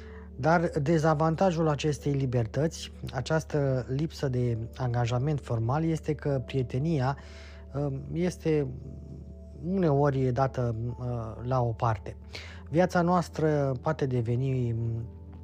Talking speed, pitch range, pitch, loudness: 85 wpm, 115-155 Hz, 130 Hz, -29 LUFS